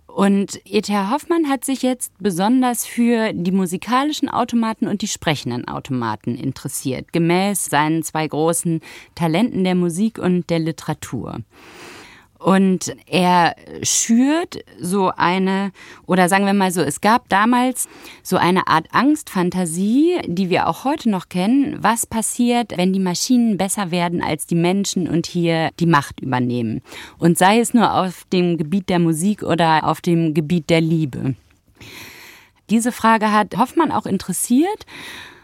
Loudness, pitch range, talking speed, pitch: -18 LUFS, 165-225 Hz, 145 wpm, 185 Hz